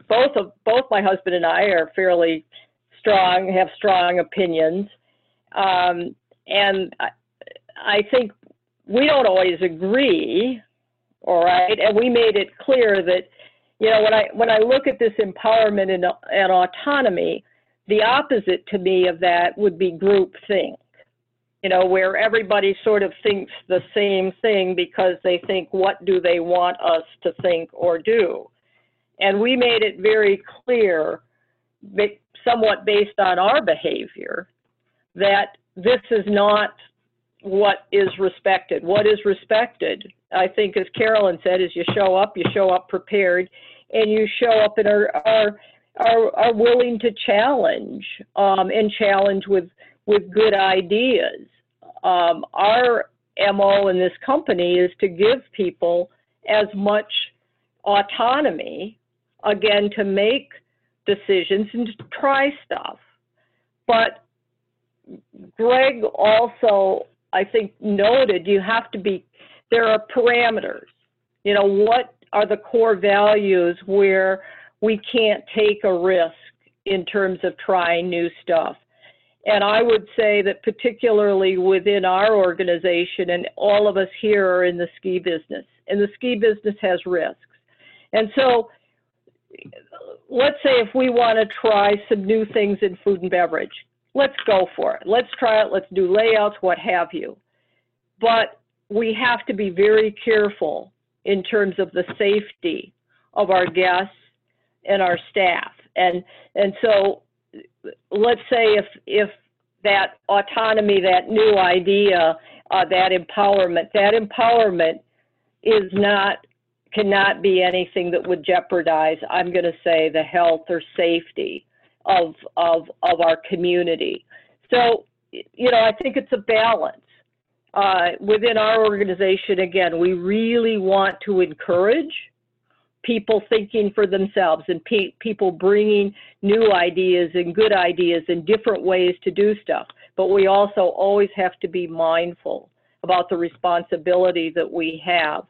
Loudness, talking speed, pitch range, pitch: -19 LUFS, 140 wpm, 180-220 Hz, 200 Hz